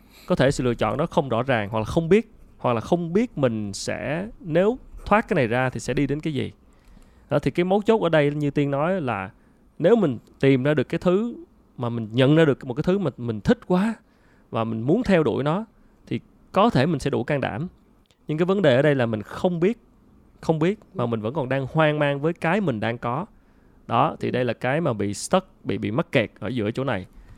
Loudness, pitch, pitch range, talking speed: -23 LUFS, 150 Hz, 120-180 Hz, 250 wpm